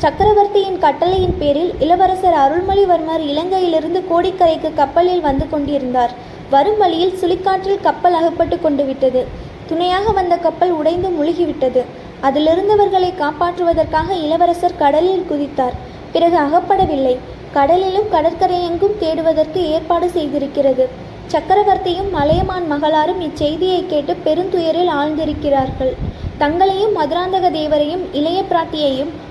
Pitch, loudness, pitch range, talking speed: 335 Hz, -15 LUFS, 300-365 Hz, 95 wpm